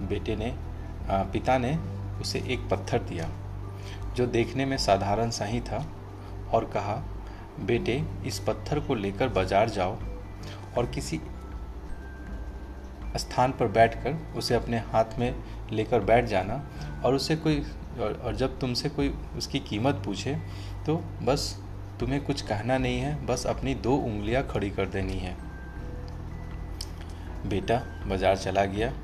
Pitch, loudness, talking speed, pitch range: 100 Hz, -29 LUFS, 135 wpm, 95-120 Hz